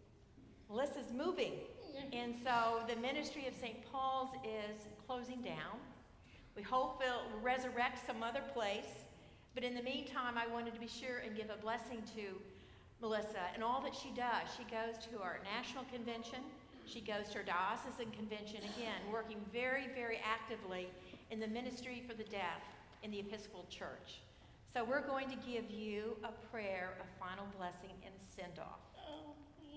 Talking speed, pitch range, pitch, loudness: 165 wpm, 215-255 Hz, 235 Hz, -44 LUFS